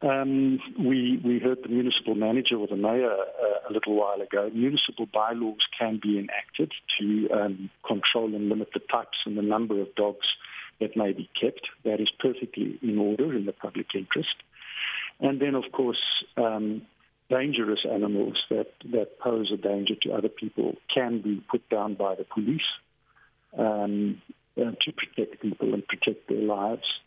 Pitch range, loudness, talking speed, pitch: 105-125 Hz, -27 LUFS, 165 wpm, 110 Hz